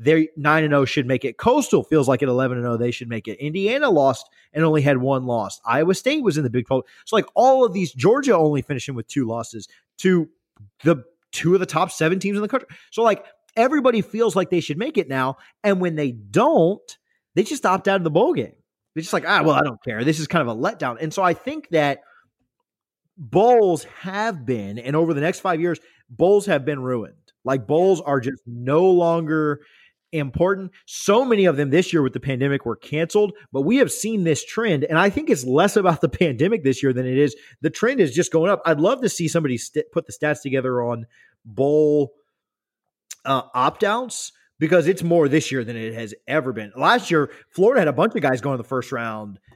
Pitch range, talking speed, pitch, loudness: 130-185 Hz, 230 wpm, 155 Hz, -20 LUFS